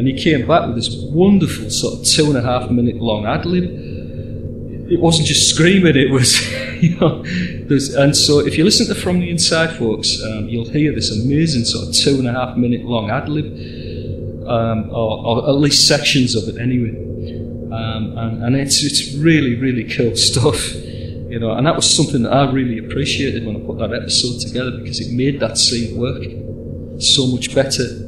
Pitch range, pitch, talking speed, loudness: 115-140 Hz, 125 Hz, 200 wpm, -15 LUFS